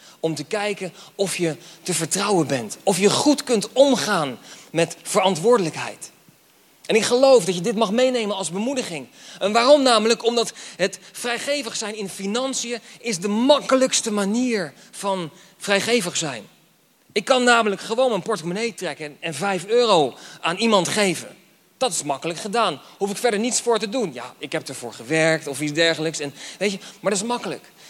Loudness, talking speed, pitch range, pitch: -21 LUFS, 170 wpm, 170-235 Hz, 205 Hz